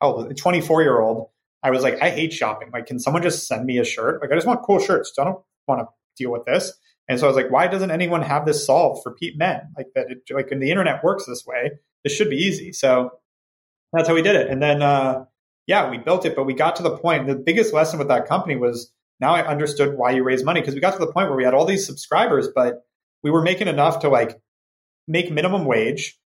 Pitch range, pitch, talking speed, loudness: 125-170 Hz, 145 Hz, 260 wpm, -20 LUFS